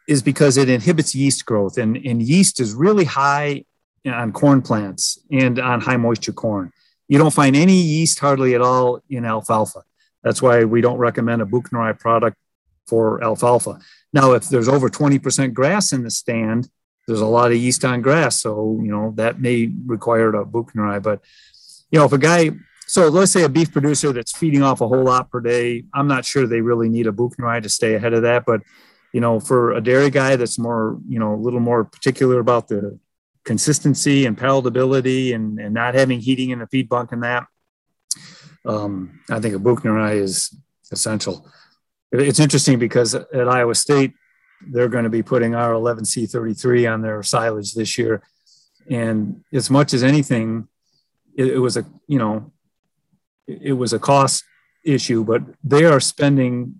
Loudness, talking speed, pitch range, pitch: -18 LUFS, 185 wpm, 115-140 Hz, 125 Hz